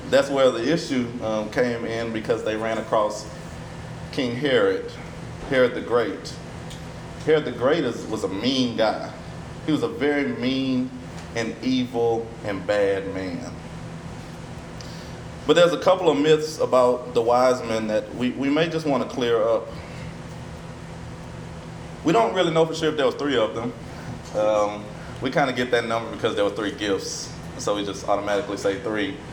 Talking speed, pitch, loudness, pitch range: 170 wpm, 125 Hz, -23 LUFS, 110-155 Hz